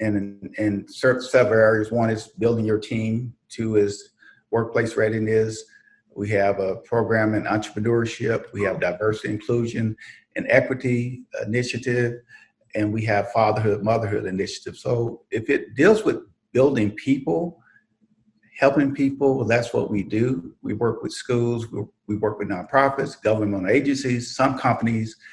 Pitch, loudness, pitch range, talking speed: 115 Hz, -23 LUFS, 105-125 Hz, 140 wpm